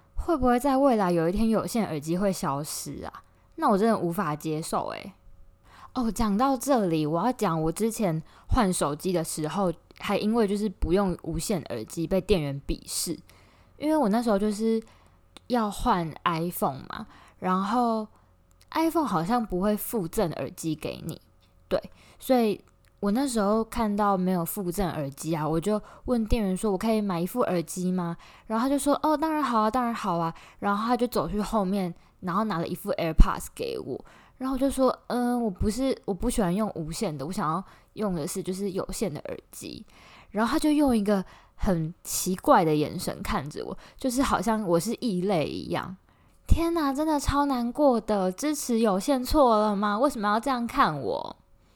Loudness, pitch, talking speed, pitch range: -27 LUFS, 210 Hz, 280 characters per minute, 180-240 Hz